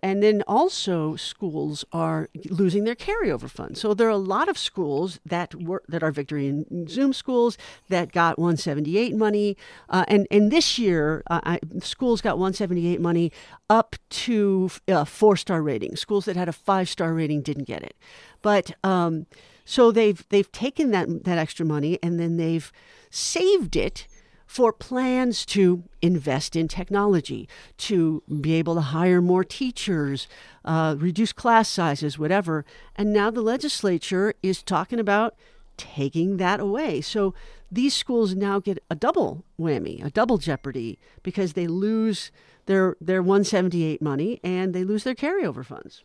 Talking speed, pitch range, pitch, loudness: 160 wpm, 165-215 Hz, 185 Hz, -24 LUFS